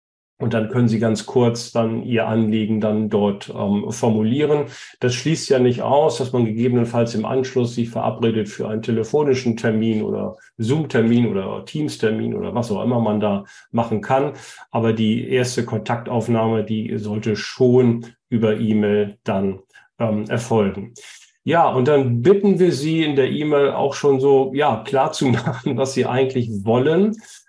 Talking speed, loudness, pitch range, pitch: 160 wpm, -19 LUFS, 110-135 Hz, 115 Hz